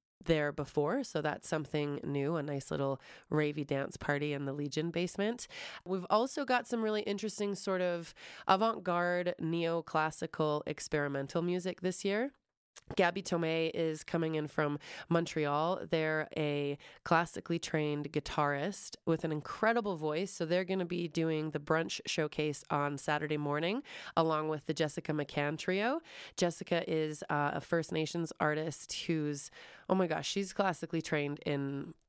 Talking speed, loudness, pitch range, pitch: 150 wpm, -34 LUFS, 150-180 Hz, 160 Hz